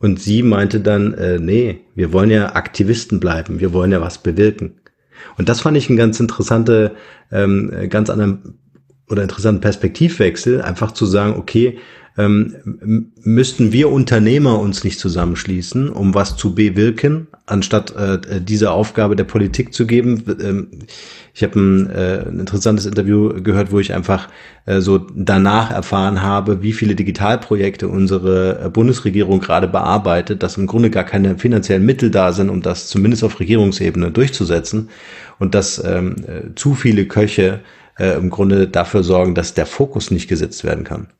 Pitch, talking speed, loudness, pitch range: 105 Hz, 155 wpm, -15 LUFS, 95-110 Hz